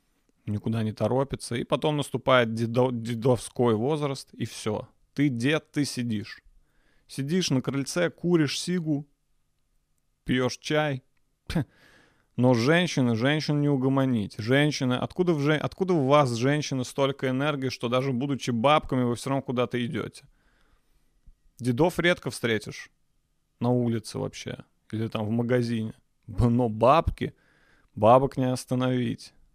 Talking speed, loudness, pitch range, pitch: 125 wpm, -26 LUFS, 120-145 Hz, 130 Hz